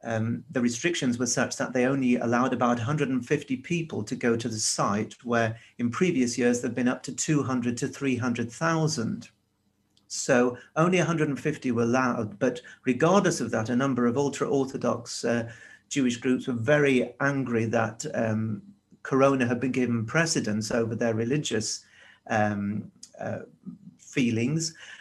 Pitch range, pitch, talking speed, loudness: 115-140 Hz, 125 Hz, 145 wpm, -27 LUFS